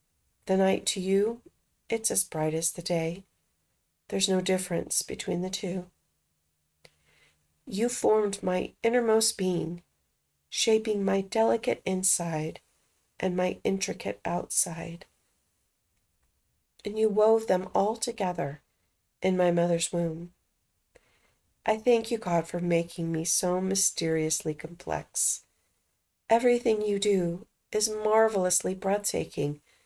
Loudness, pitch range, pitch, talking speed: -28 LUFS, 170-215 Hz, 185 Hz, 110 wpm